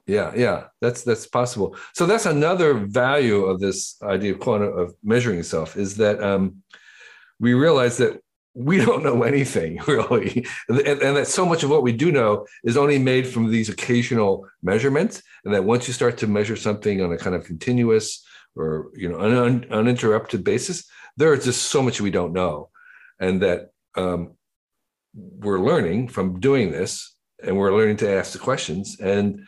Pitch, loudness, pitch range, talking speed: 110 Hz, -21 LUFS, 95-125 Hz, 185 wpm